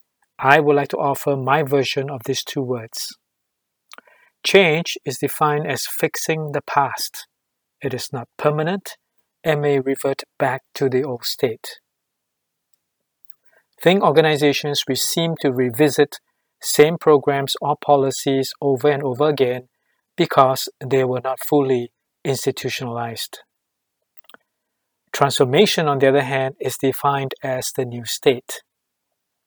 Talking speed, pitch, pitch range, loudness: 125 wpm, 140 Hz, 130-150 Hz, -19 LUFS